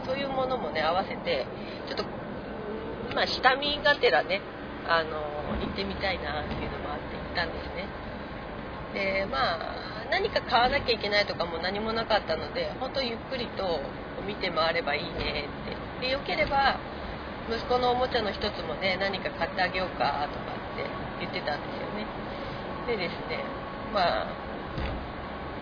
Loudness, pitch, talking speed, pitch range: -29 LUFS, 195 Hz, 325 characters per minute, 160-255 Hz